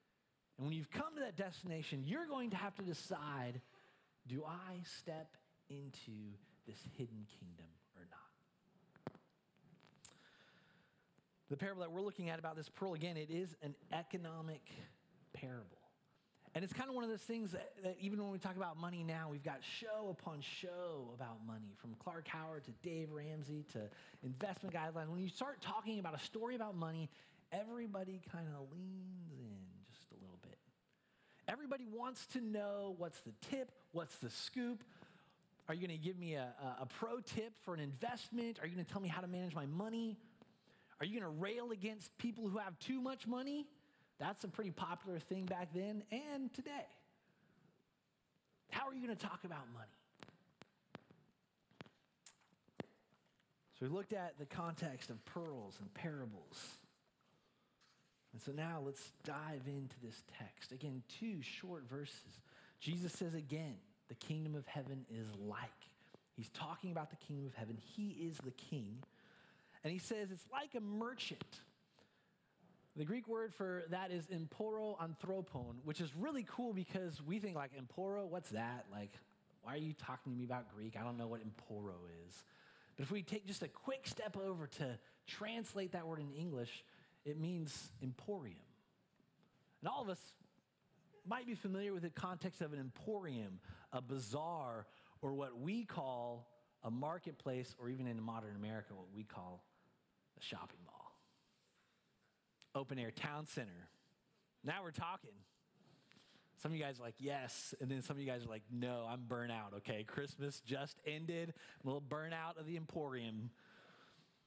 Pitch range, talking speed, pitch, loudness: 130-195 Hz, 165 wpm, 165 Hz, -48 LUFS